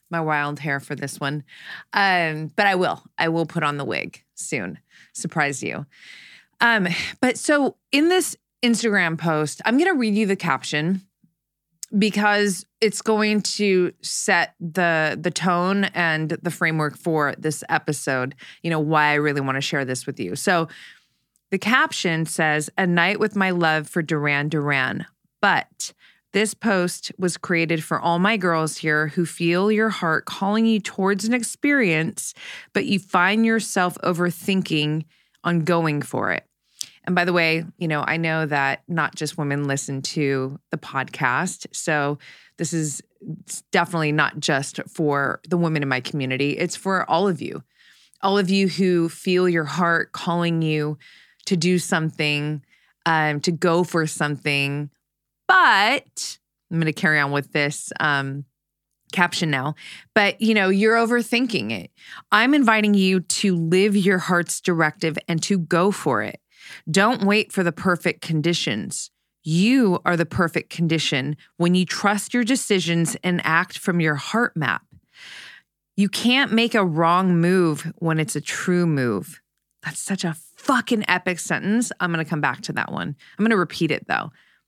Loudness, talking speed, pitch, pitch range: -21 LUFS, 165 wpm, 170 Hz, 155-195 Hz